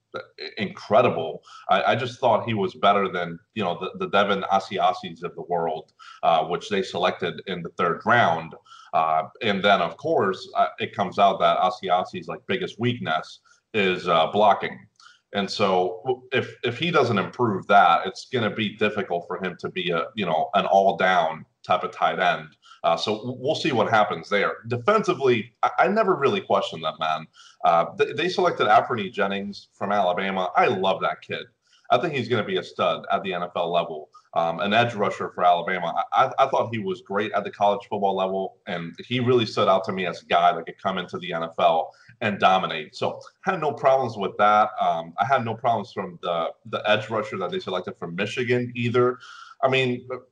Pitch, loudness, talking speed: 125 Hz, -23 LUFS, 200 wpm